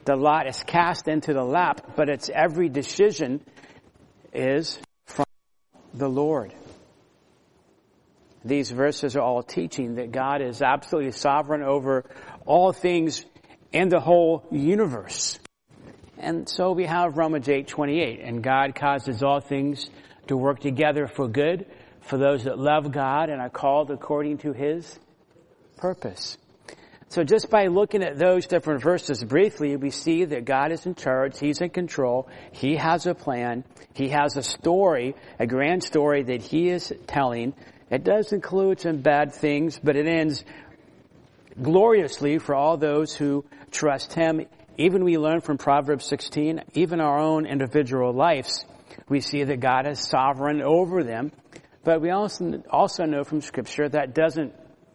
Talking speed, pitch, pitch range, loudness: 150 wpm, 145 Hz, 140-165 Hz, -24 LUFS